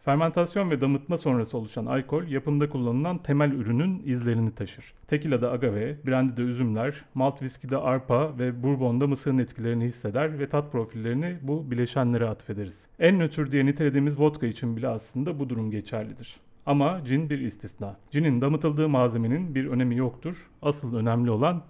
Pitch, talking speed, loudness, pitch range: 130 Hz, 150 wpm, -27 LUFS, 120-150 Hz